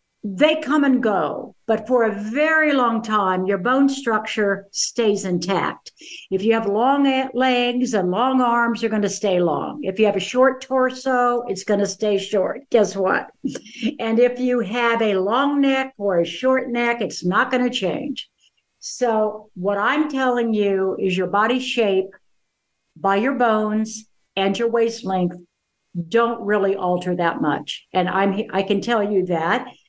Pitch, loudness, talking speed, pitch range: 220 Hz, -20 LUFS, 170 wpm, 195-250 Hz